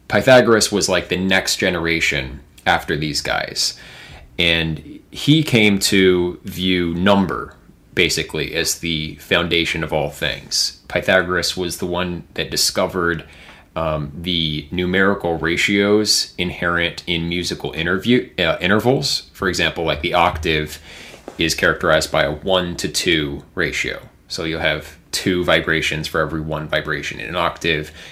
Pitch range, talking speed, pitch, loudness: 80-95 Hz, 135 wpm, 85 Hz, -18 LUFS